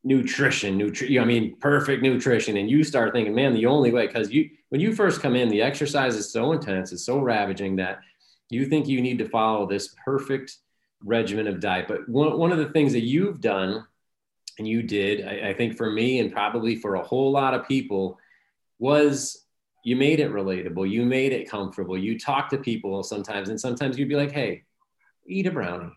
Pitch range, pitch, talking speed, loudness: 105-140 Hz, 120 Hz, 205 wpm, -24 LUFS